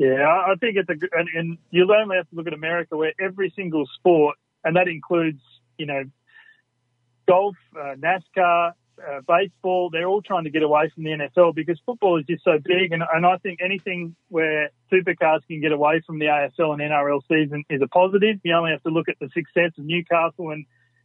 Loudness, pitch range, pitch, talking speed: -21 LUFS, 150-180 Hz, 165 Hz, 210 wpm